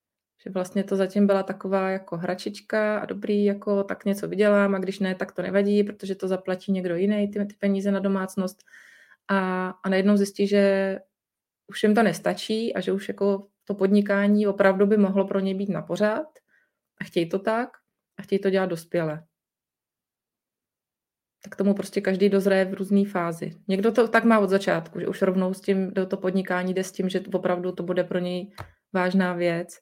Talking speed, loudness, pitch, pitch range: 195 wpm, -24 LUFS, 195 Hz, 185-200 Hz